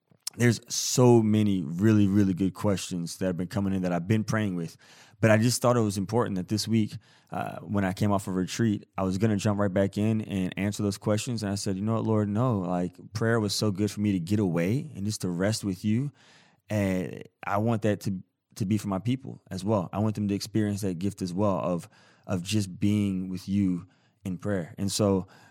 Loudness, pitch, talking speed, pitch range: -27 LUFS, 105 Hz, 240 wpm, 95-110 Hz